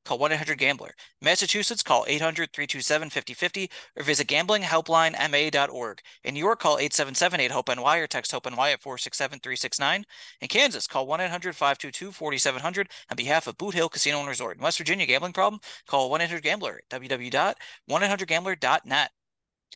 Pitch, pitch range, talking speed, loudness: 155 Hz, 140-180 Hz, 120 wpm, -25 LUFS